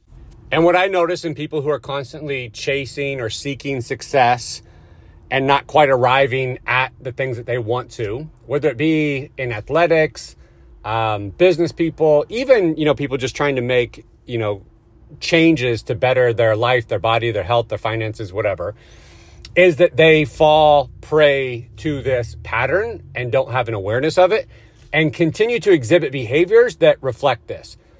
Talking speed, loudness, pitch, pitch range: 165 wpm, -17 LUFS, 130 Hz, 115-155 Hz